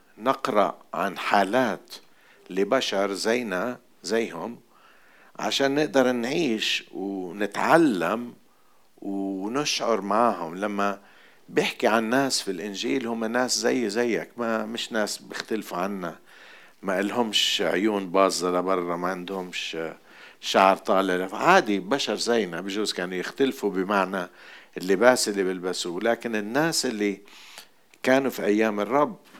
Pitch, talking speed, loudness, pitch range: 105 Hz, 110 wpm, -25 LUFS, 95-120 Hz